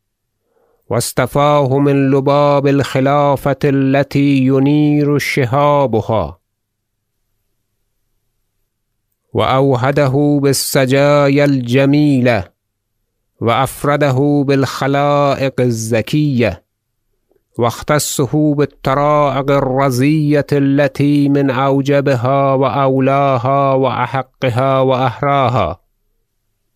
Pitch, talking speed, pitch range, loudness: 135 Hz, 50 wpm, 115-145 Hz, -13 LUFS